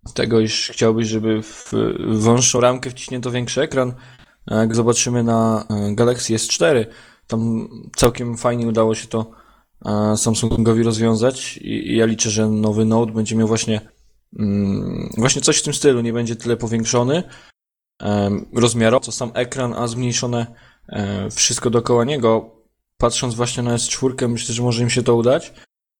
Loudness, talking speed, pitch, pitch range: -18 LUFS, 150 wpm, 115 Hz, 110-125 Hz